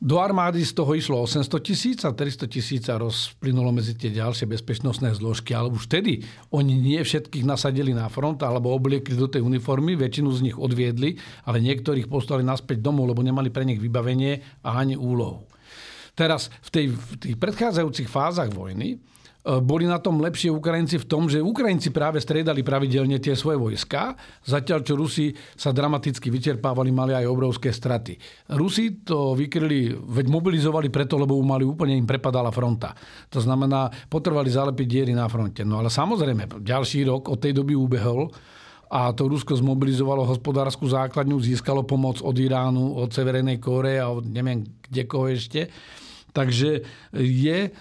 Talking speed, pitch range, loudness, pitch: 165 wpm, 125-150 Hz, -24 LUFS, 135 Hz